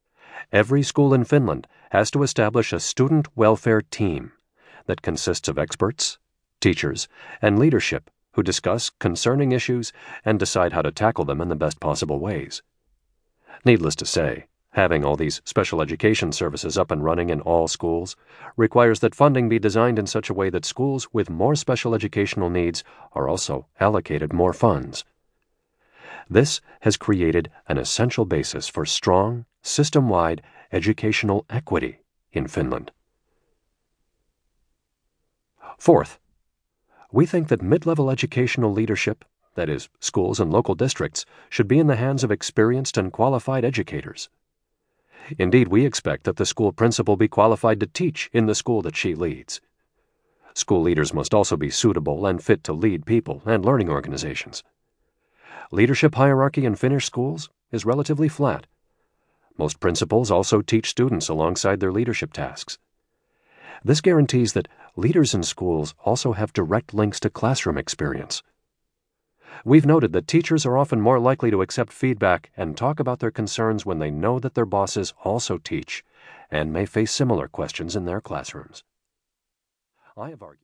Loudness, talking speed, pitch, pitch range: -22 LUFS, 150 wpm, 115 Hz, 105-135 Hz